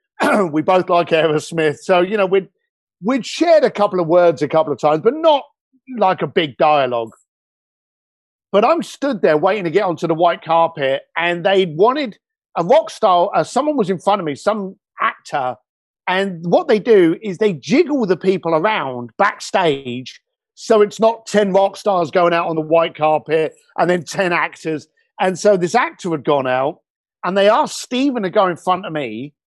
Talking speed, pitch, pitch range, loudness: 190 wpm, 185 Hz, 160-225 Hz, -17 LUFS